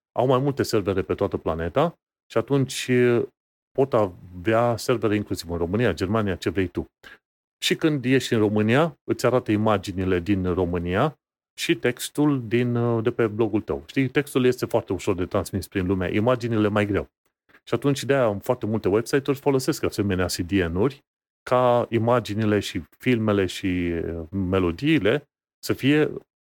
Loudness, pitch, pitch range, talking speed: -23 LUFS, 115 Hz, 100-130 Hz, 150 wpm